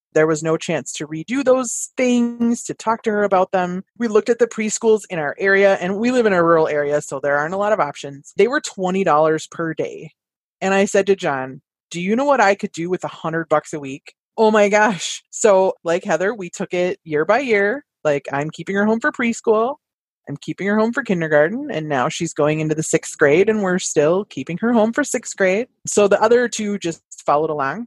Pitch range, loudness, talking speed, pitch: 155-220 Hz, -18 LUFS, 235 wpm, 190 Hz